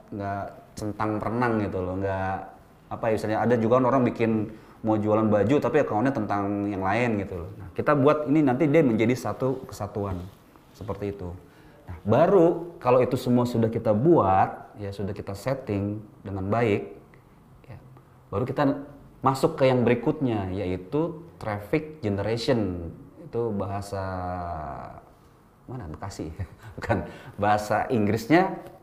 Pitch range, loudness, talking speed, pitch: 100-125 Hz, -25 LUFS, 135 wpm, 110 Hz